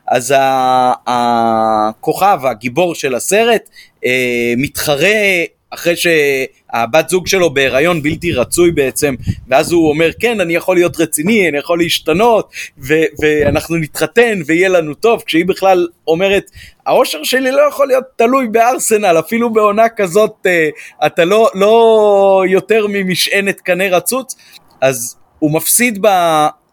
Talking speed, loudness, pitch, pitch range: 120 wpm, -12 LUFS, 170 Hz, 150-210 Hz